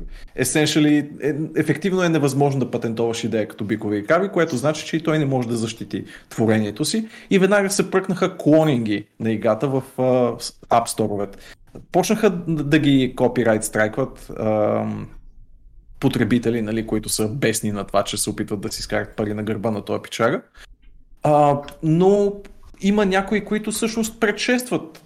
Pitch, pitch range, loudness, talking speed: 130 Hz, 110-165 Hz, -21 LUFS, 155 wpm